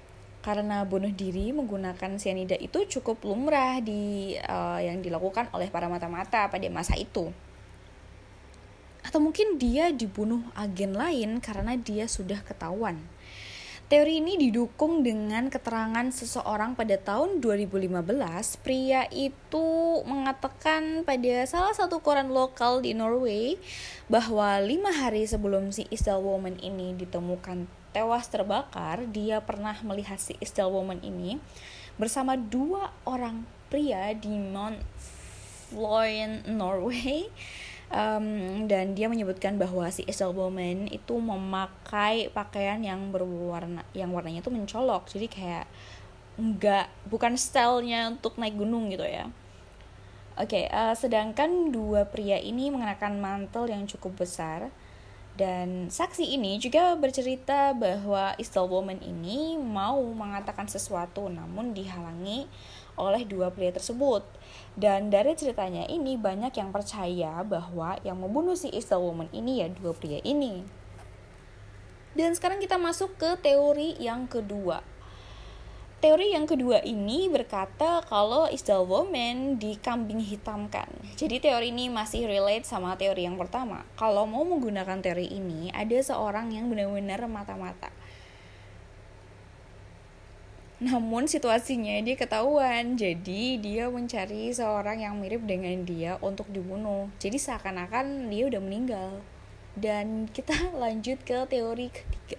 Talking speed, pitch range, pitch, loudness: 125 wpm, 185-250 Hz, 210 Hz, -29 LUFS